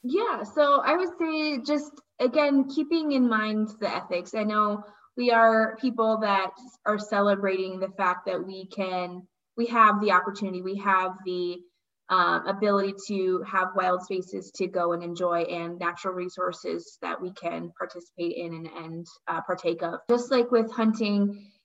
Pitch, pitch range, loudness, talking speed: 195 Hz, 180-225 Hz, -26 LUFS, 165 wpm